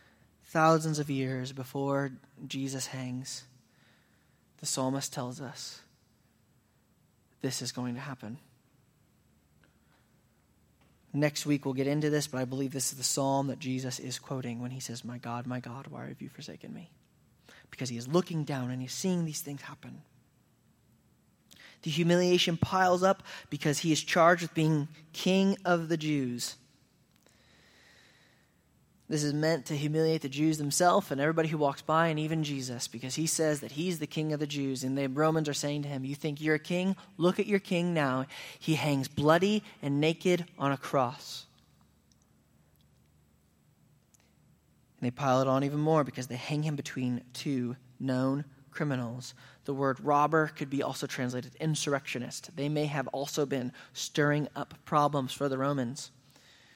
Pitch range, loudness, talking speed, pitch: 125-155 Hz, -31 LUFS, 165 wpm, 140 Hz